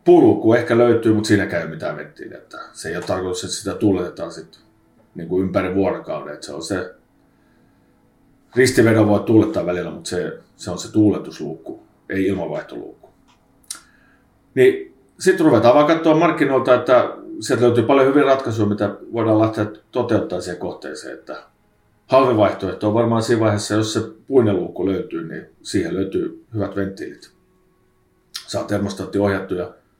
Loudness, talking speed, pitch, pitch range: -18 LUFS, 135 wpm, 115 Hz, 100-140 Hz